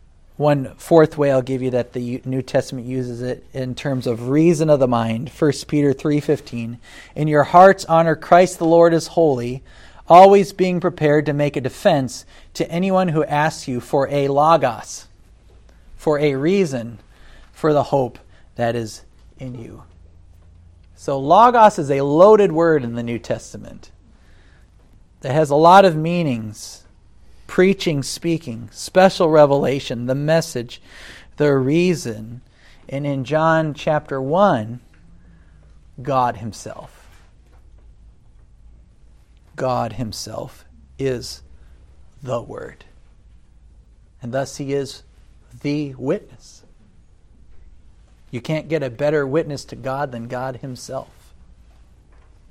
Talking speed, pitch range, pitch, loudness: 125 wpm, 100-150 Hz, 130 Hz, -18 LUFS